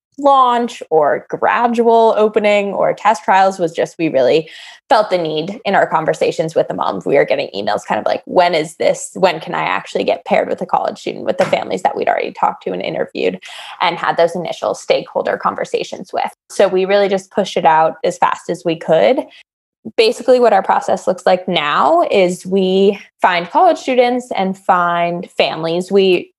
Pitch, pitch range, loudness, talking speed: 195 Hz, 175-245 Hz, -15 LUFS, 195 wpm